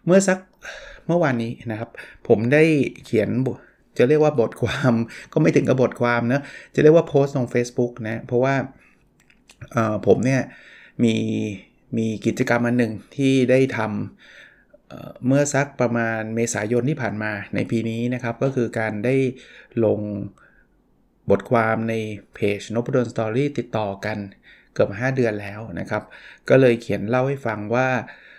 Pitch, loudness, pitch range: 120 Hz, -21 LUFS, 110-130 Hz